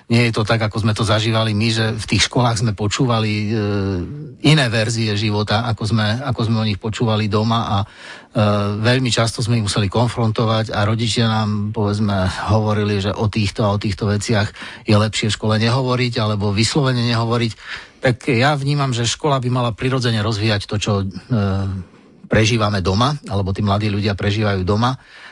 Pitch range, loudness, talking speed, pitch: 105-120 Hz, -18 LUFS, 180 wpm, 110 Hz